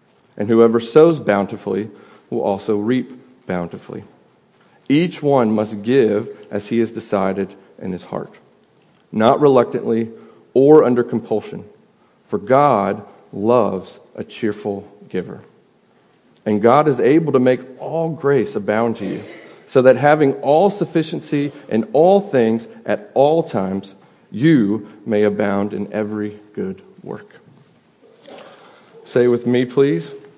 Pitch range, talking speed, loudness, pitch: 105-145 Hz, 125 wpm, -17 LUFS, 120 Hz